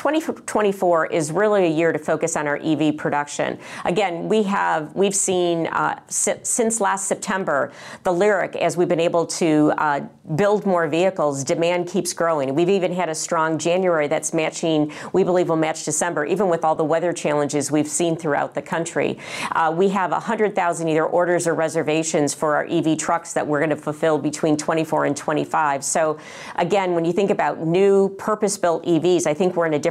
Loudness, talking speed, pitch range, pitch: -20 LUFS, 190 wpm, 155-185 Hz, 165 Hz